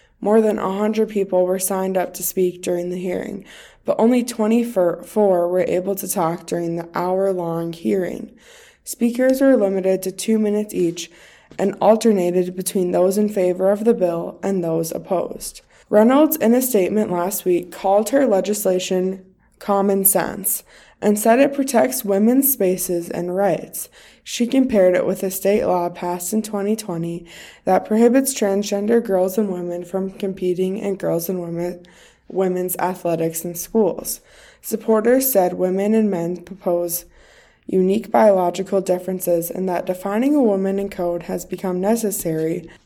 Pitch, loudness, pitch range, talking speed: 190 Hz, -19 LUFS, 180-215 Hz, 150 wpm